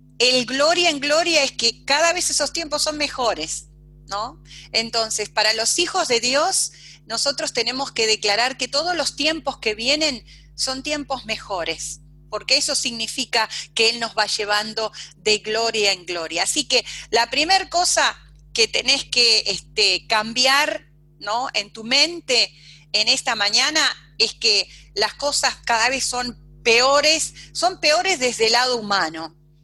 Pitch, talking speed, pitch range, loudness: 230 Hz, 150 wpm, 200-280 Hz, -19 LUFS